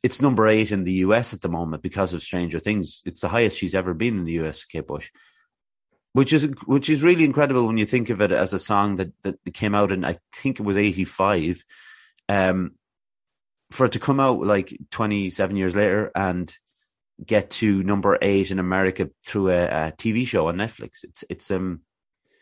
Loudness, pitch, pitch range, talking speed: -22 LUFS, 100 Hz, 90-115 Hz, 205 wpm